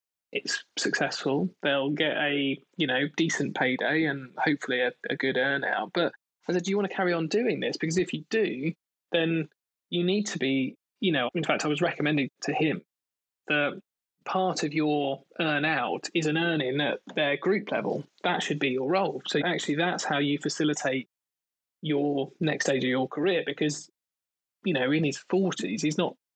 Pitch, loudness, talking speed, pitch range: 150 Hz, -28 LUFS, 190 wpm, 140-170 Hz